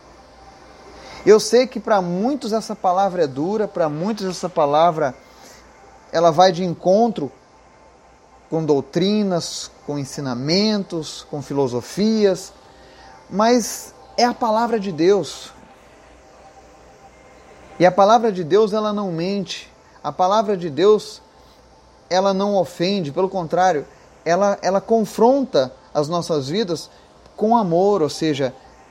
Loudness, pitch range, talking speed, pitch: -19 LUFS, 155-215 Hz, 115 wpm, 185 Hz